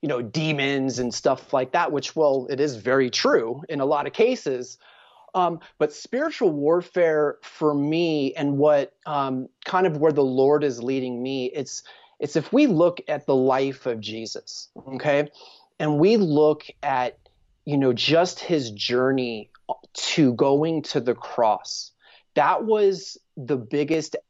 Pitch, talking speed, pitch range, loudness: 145 Hz, 160 wpm, 130-160 Hz, -23 LUFS